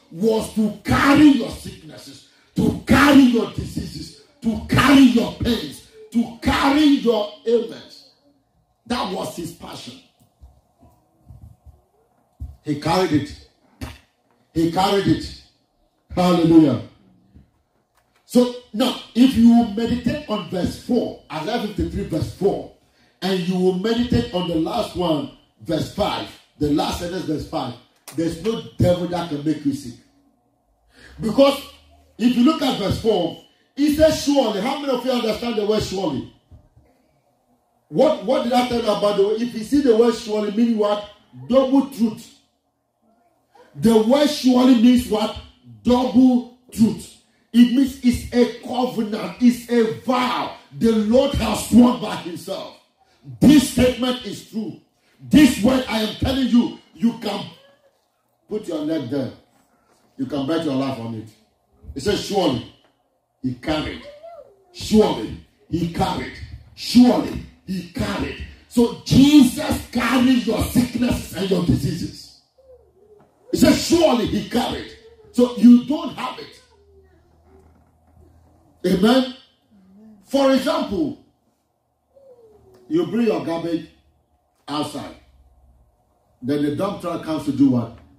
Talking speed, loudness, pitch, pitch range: 130 wpm, -19 LUFS, 230 Hz, 170-255 Hz